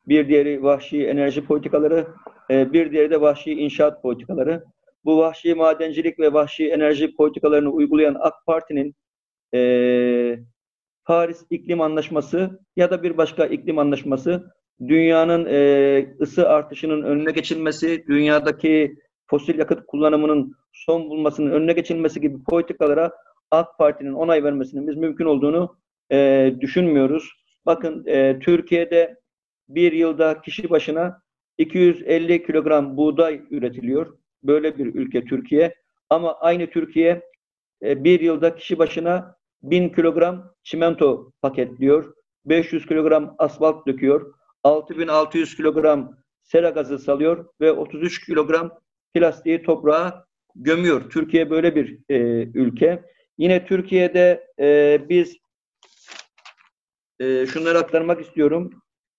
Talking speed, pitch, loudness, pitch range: 110 wpm, 155 Hz, -19 LUFS, 145-170 Hz